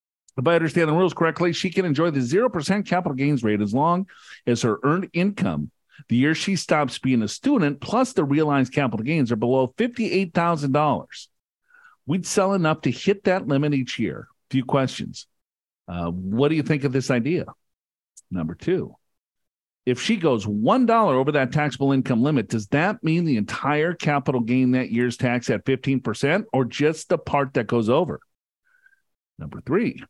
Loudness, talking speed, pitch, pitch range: -22 LUFS, 170 wpm, 145 Hz, 130-180 Hz